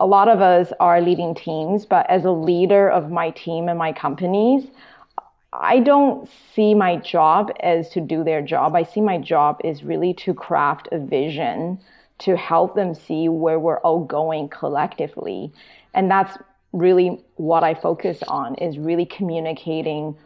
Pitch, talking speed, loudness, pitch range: 175 Hz, 165 wpm, -19 LUFS, 160-195 Hz